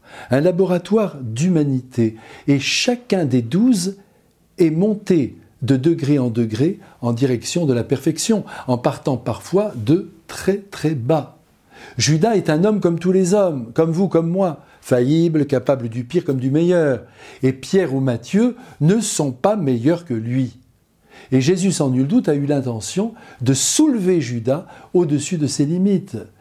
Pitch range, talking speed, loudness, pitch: 130-185 Hz, 155 wpm, -19 LUFS, 155 Hz